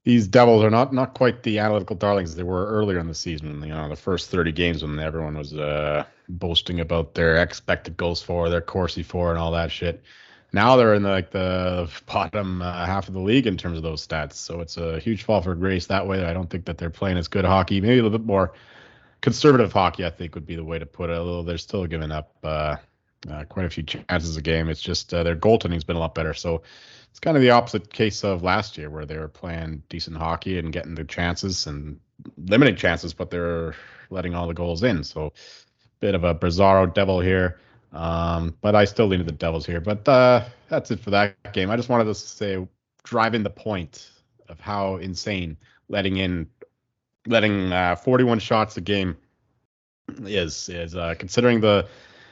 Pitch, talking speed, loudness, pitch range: 90 Hz, 220 wpm, -23 LUFS, 85-105 Hz